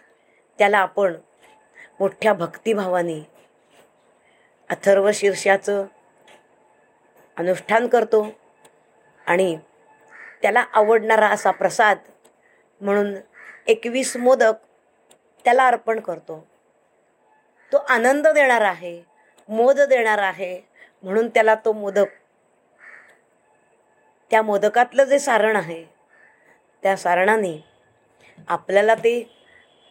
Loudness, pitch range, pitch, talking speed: -19 LUFS, 190-230 Hz, 210 Hz, 80 wpm